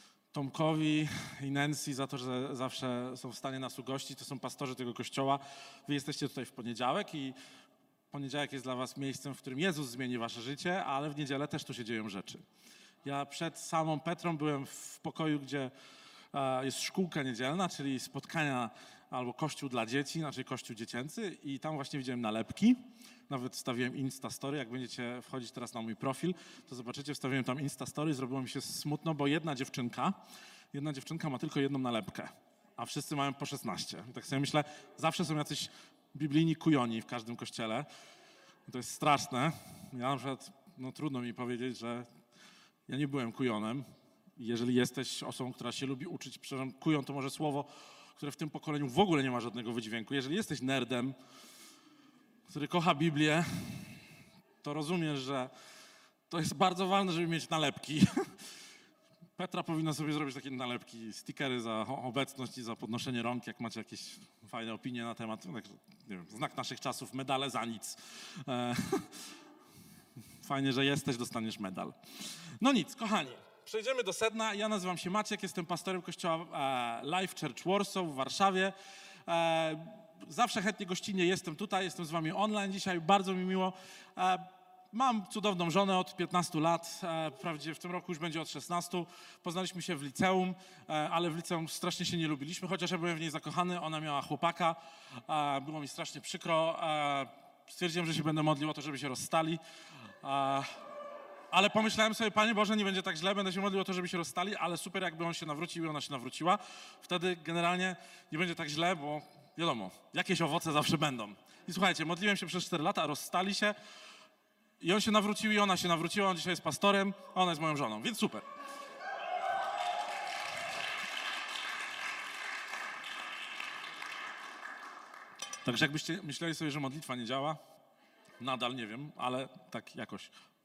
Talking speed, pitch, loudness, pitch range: 165 wpm, 155 Hz, -35 LUFS, 135-180 Hz